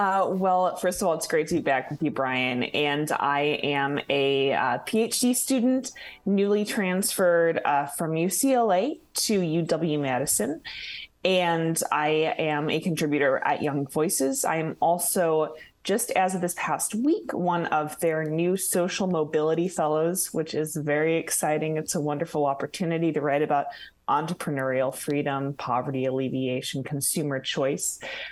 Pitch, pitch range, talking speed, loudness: 160 Hz, 145-180 Hz, 145 wpm, -25 LUFS